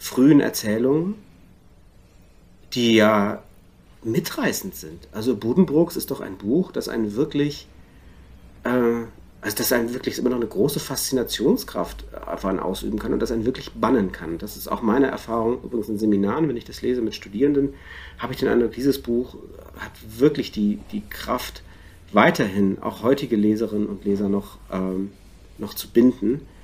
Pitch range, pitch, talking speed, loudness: 100-125 Hz, 110 Hz, 155 wpm, -22 LUFS